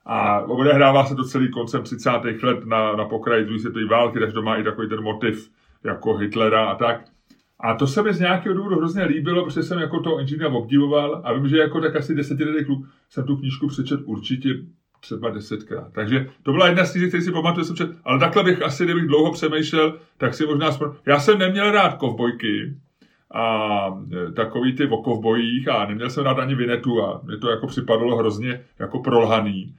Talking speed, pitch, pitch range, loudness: 195 wpm, 135 Hz, 115-155 Hz, -21 LUFS